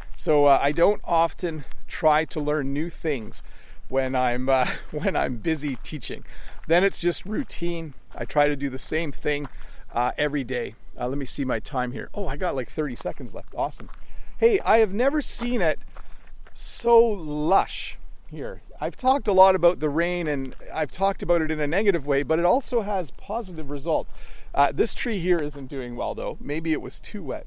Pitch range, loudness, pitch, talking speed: 140-190 Hz, -25 LUFS, 155 Hz, 195 wpm